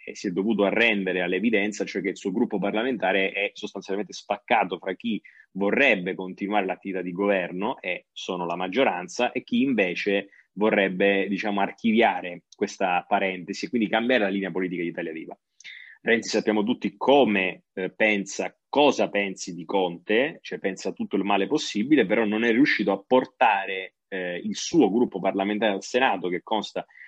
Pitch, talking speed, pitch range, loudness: 100 Hz, 165 wpm, 95-110 Hz, -25 LUFS